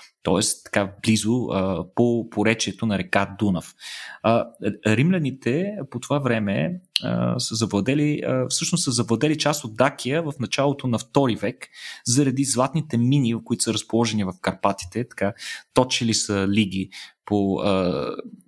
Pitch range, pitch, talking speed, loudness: 105-135 Hz, 115 Hz, 140 wpm, -23 LUFS